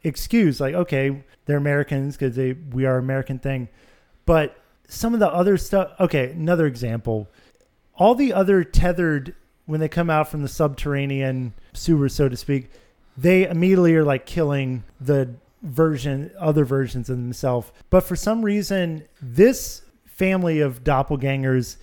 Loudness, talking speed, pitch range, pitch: -21 LUFS, 150 wpm, 130-175 Hz, 145 Hz